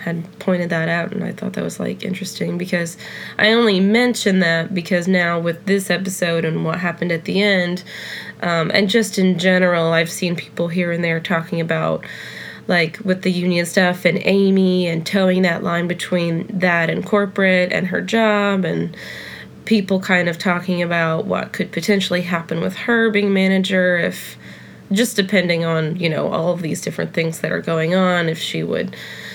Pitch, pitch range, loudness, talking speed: 180 Hz, 170-195 Hz, -18 LUFS, 185 wpm